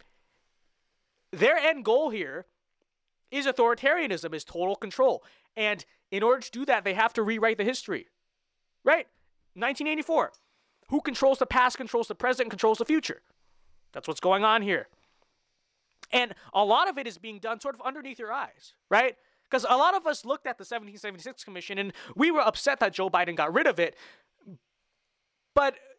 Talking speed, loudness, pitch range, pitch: 170 wpm, -27 LUFS, 210-280 Hz, 245 Hz